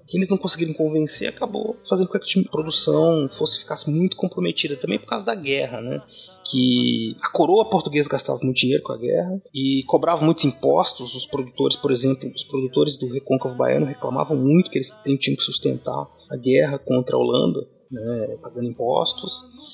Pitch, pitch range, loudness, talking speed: 145 Hz, 130-180 Hz, -21 LUFS, 180 wpm